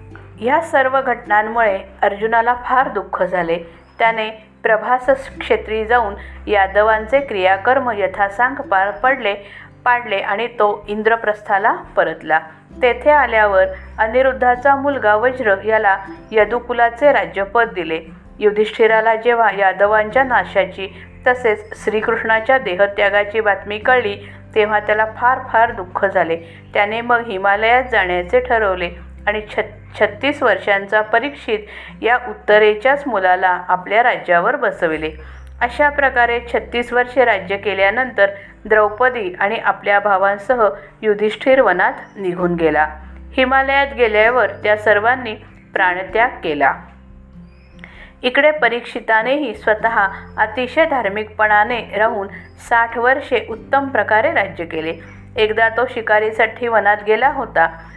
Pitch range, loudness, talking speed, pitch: 195-245 Hz, -16 LUFS, 100 wpm, 215 Hz